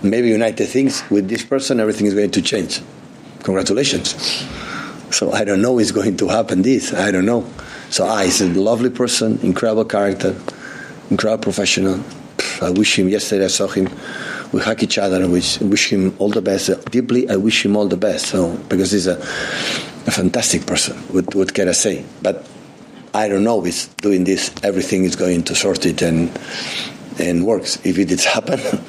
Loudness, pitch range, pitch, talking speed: -17 LUFS, 95-110 Hz, 100 Hz, 195 wpm